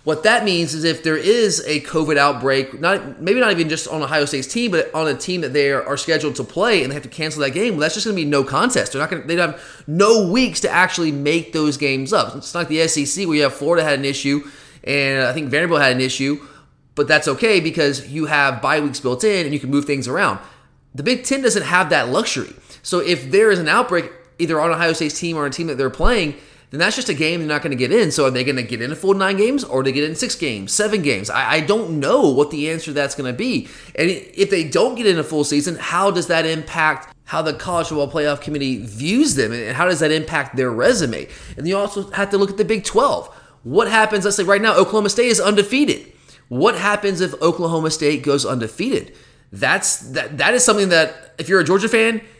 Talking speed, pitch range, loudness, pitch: 255 wpm, 145-195 Hz, -18 LUFS, 155 Hz